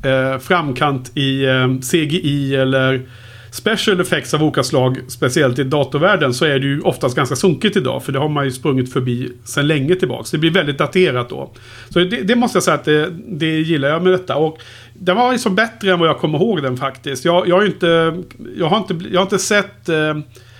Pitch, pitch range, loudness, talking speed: 150 Hz, 135-180 Hz, -16 LUFS, 215 wpm